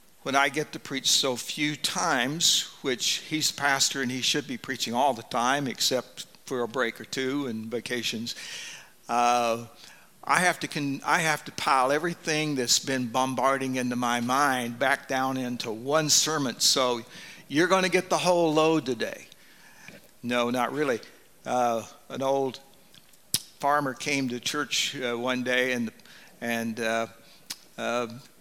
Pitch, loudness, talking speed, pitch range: 130 Hz, -26 LUFS, 160 wpm, 120-150 Hz